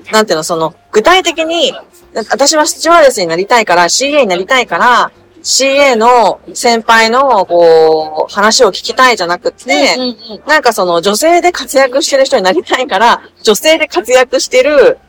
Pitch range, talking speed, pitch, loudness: 195-305 Hz, 335 characters per minute, 255 Hz, -9 LUFS